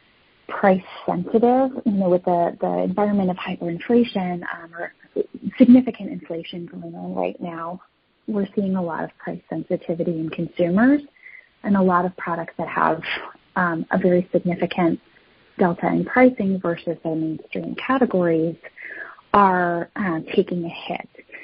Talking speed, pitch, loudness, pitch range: 140 wpm, 180 Hz, -21 LUFS, 170-210 Hz